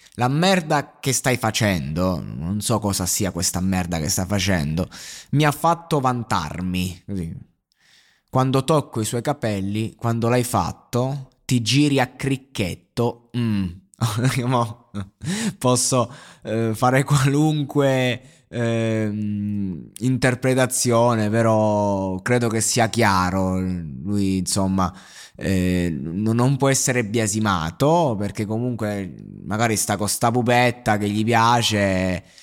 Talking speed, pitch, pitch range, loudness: 110 wpm, 115 Hz, 100-125 Hz, -21 LUFS